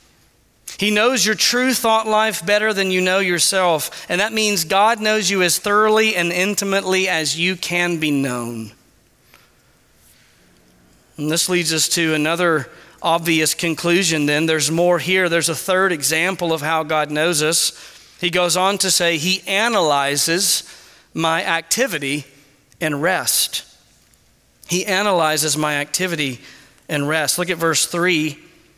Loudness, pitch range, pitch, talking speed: -17 LUFS, 155-190 Hz, 170 Hz, 140 wpm